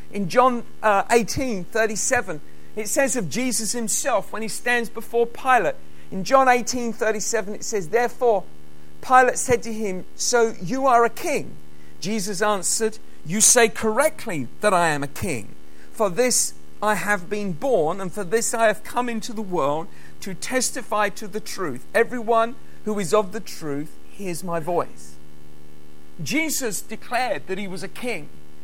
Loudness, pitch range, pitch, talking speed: -22 LUFS, 170-235 Hz, 215 Hz, 155 wpm